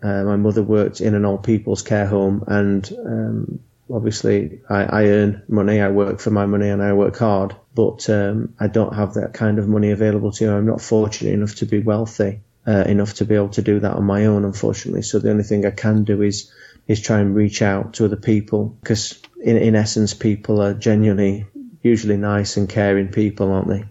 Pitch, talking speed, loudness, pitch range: 105 Hz, 220 wpm, -18 LUFS, 100-110 Hz